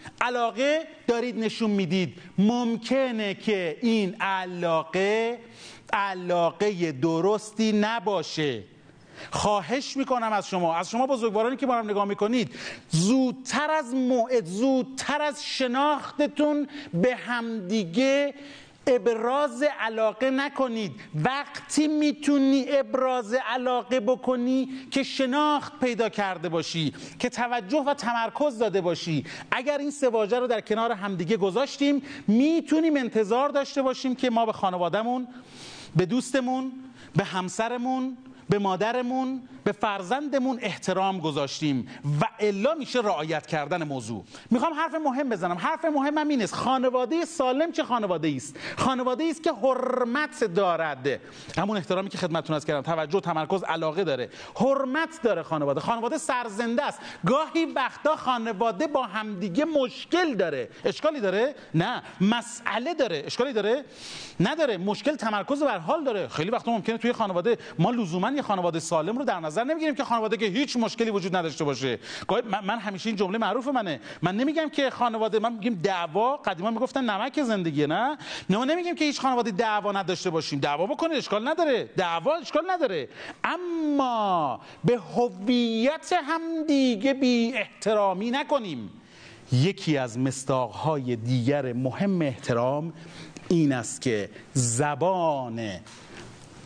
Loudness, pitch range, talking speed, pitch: -26 LUFS, 185-270 Hz, 130 wpm, 230 Hz